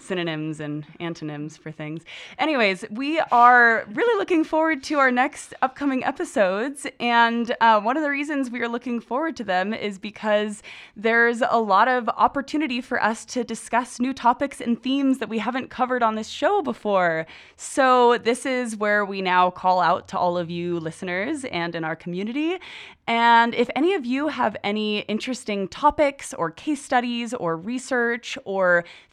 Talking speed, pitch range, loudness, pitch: 170 wpm, 195-265 Hz, -22 LUFS, 235 Hz